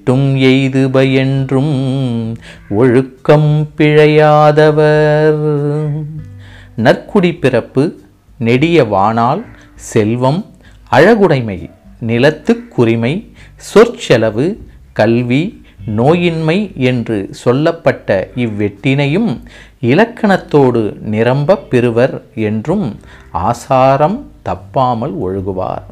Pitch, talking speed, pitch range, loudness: 130 Hz, 55 wpm, 110-150 Hz, -12 LUFS